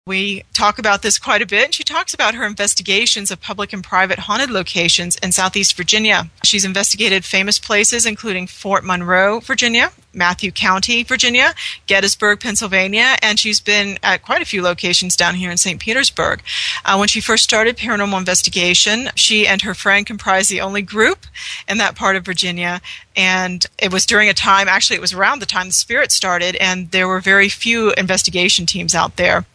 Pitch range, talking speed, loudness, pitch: 185-215 Hz, 185 wpm, -14 LUFS, 195 Hz